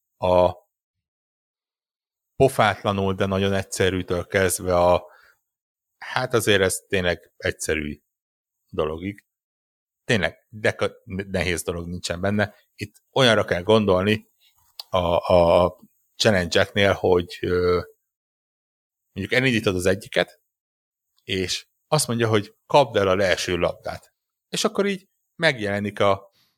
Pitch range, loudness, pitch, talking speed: 90-105 Hz, -22 LUFS, 95 Hz, 105 wpm